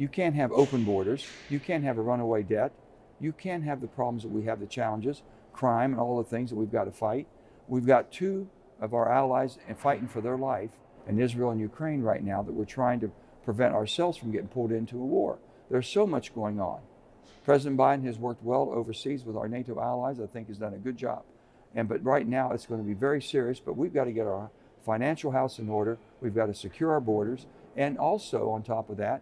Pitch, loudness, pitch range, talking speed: 120 Hz, -30 LUFS, 110-135 Hz, 230 wpm